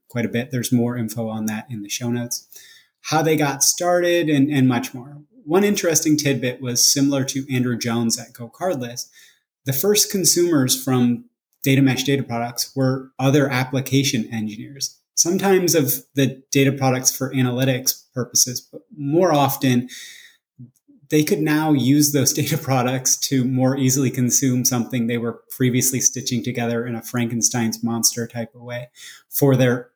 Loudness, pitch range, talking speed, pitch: -19 LUFS, 120-140 Hz, 160 wpm, 130 Hz